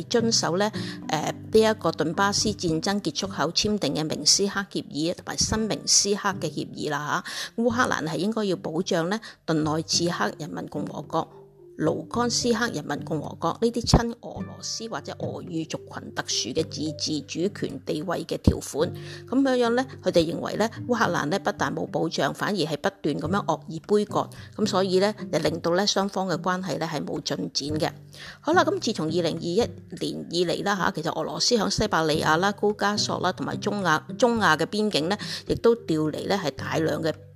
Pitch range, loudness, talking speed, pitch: 155-210 Hz, -25 LUFS, 290 characters per minute, 180 Hz